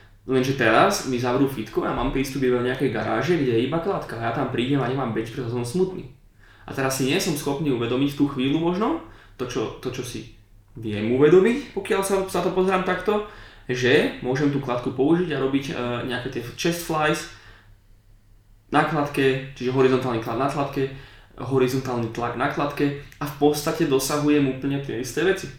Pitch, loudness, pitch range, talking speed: 135 Hz, -23 LUFS, 120-150 Hz, 185 wpm